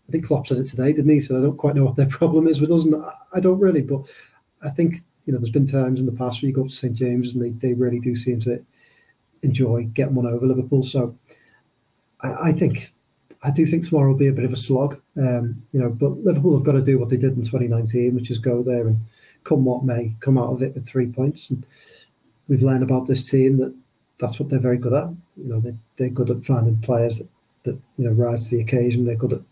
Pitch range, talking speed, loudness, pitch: 125-140 Hz, 260 wpm, -21 LUFS, 130 Hz